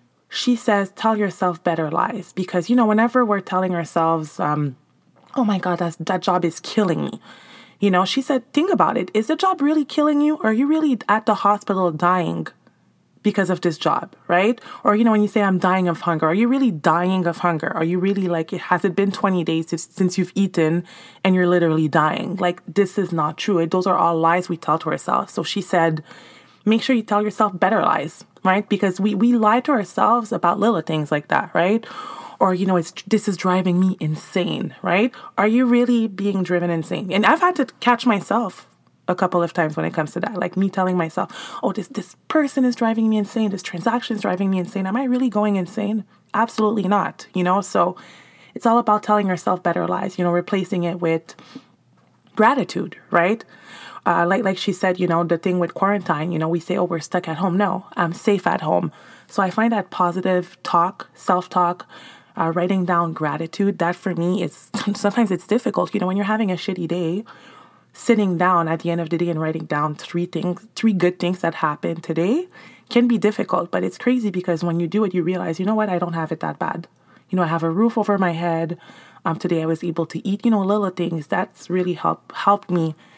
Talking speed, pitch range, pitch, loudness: 225 wpm, 170-215 Hz, 185 Hz, -20 LUFS